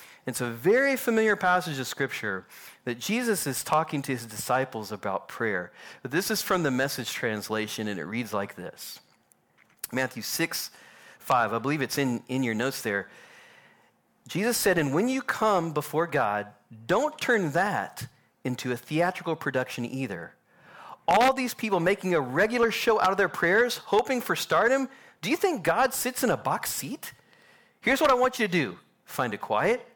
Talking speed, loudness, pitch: 175 wpm, -27 LUFS, 155 Hz